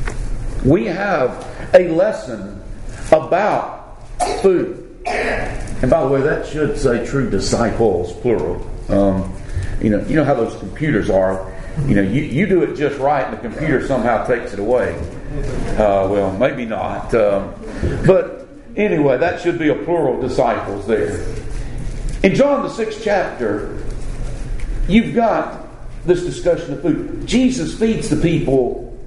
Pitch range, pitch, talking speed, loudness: 110-185 Hz, 135 Hz, 140 wpm, -18 LUFS